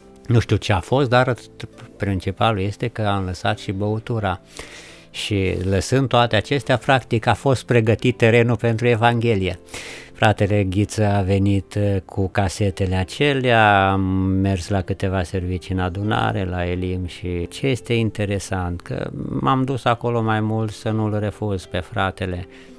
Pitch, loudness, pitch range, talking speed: 105 Hz, -20 LUFS, 95-115 Hz, 145 wpm